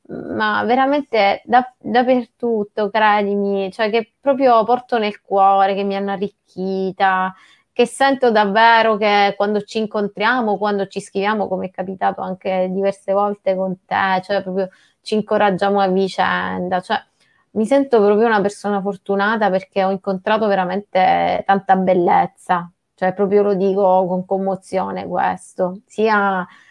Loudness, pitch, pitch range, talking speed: -18 LUFS, 200 Hz, 190-215 Hz, 135 wpm